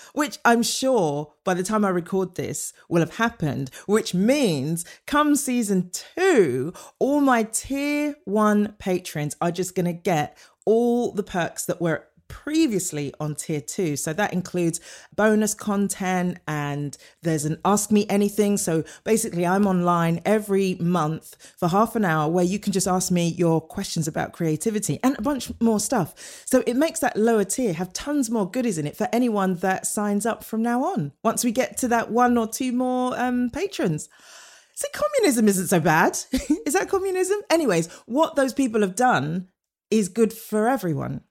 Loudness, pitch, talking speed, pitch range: -23 LUFS, 205 Hz, 175 wpm, 175-245 Hz